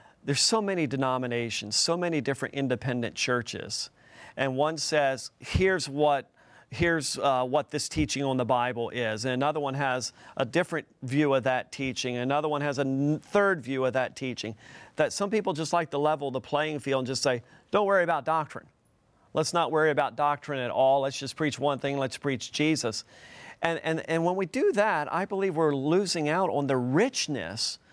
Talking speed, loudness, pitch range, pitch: 190 wpm, -28 LUFS, 130-160 Hz, 140 Hz